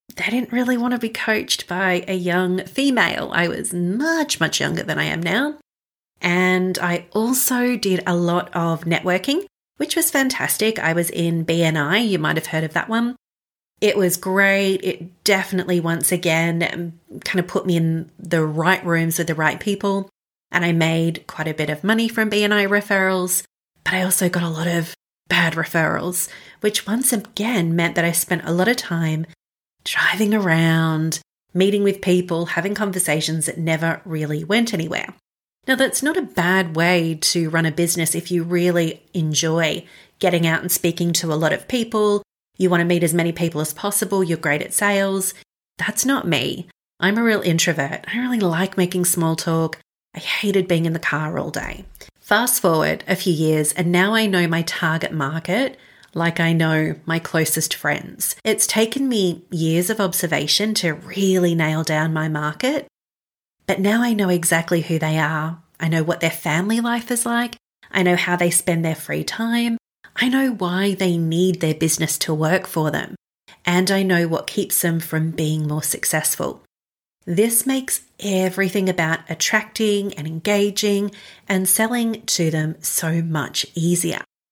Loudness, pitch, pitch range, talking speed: -20 LUFS, 180 Hz, 165-205 Hz, 175 wpm